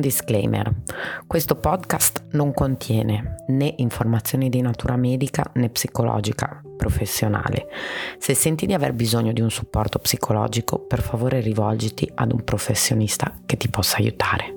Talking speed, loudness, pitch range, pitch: 130 wpm, -22 LUFS, 110-135 Hz, 120 Hz